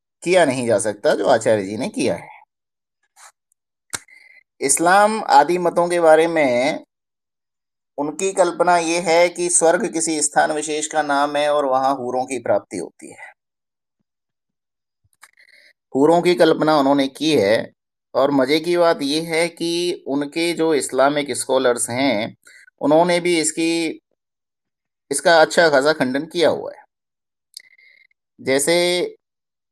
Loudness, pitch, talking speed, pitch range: -18 LUFS, 165 Hz, 125 wpm, 145-200 Hz